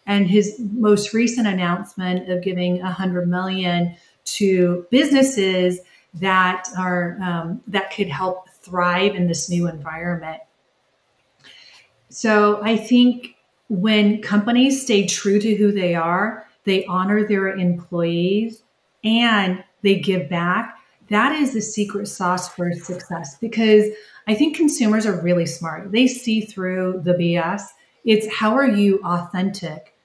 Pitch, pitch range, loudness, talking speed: 195 Hz, 180-215 Hz, -19 LUFS, 130 wpm